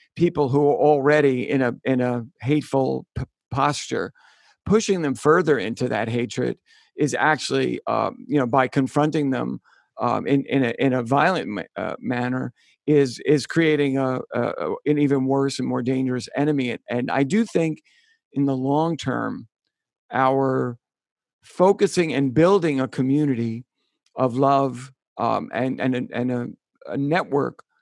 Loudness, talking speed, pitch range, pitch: -22 LUFS, 155 wpm, 125-150 Hz, 135 Hz